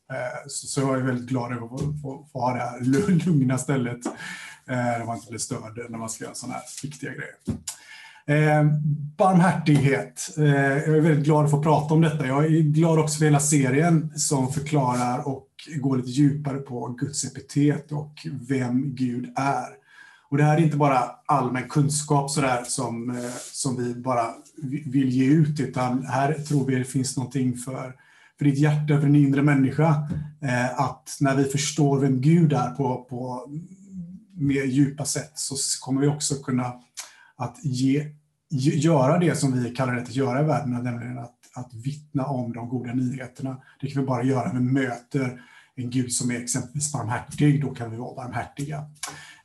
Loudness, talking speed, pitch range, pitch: -24 LUFS, 175 wpm, 125-150 Hz, 135 Hz